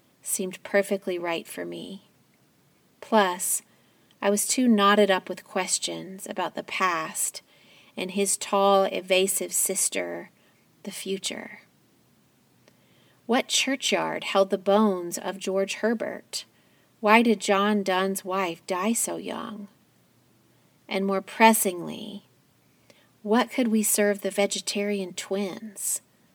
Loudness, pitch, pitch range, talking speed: -25 LUFS, 200 Hz, 190-210 Hz, 110 wpm